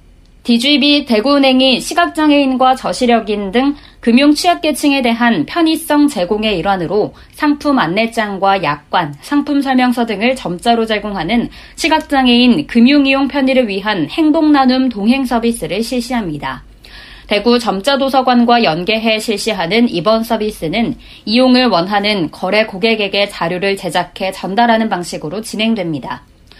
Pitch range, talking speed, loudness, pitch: 205-265 Hz, 320 characters per minute, -13 LUFS, 235 Hz